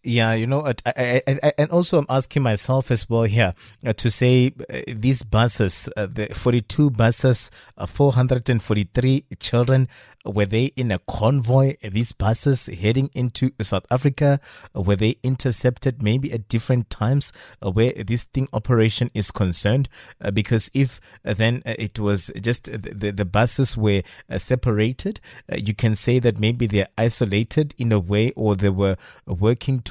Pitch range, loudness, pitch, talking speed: 105-130 Hz, -21 LUFS, 115 Hz, 160 wpm